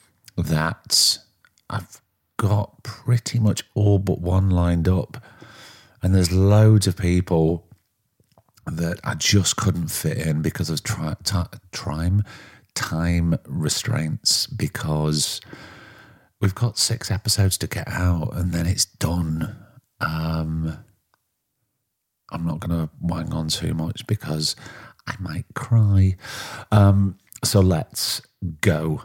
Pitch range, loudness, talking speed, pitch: 85-105 Hz, -22 LUFS, 115 wpm, 95 Hz